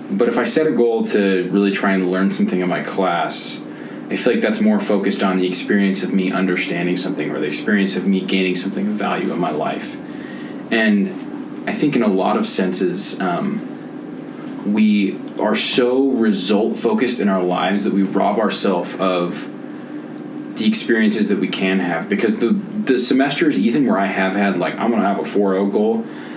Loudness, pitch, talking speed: -18 LUFS, 100 Hz, 195 wpm